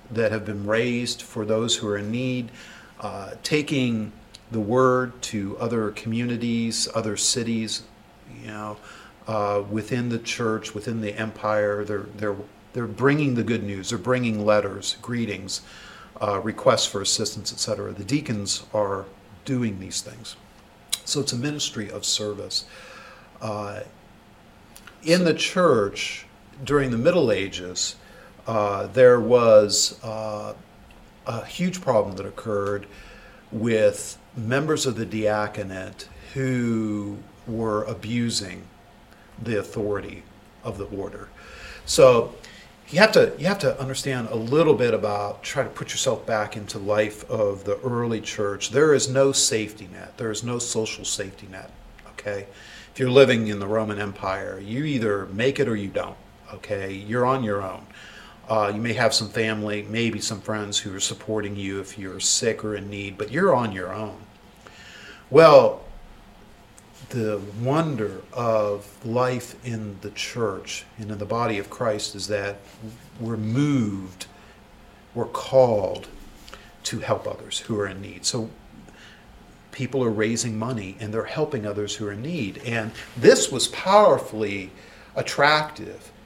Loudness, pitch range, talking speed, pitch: -23 LUFS, 105-120 Hz, 145 wpm, 110 Hz